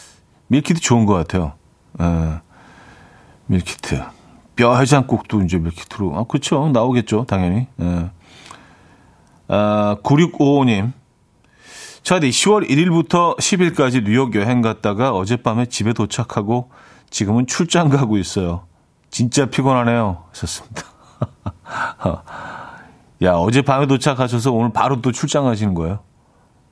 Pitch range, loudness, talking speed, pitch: 100-135 Hz, -17 LUFS, 245 characters per minute, 120 Hz